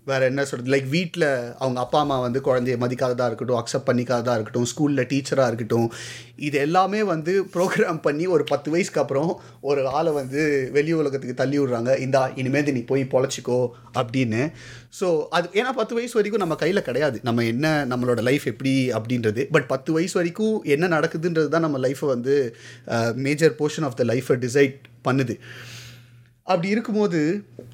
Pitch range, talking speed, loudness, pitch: 125-155 Hz, 160 wpm, -23 LUFS, 135 Hz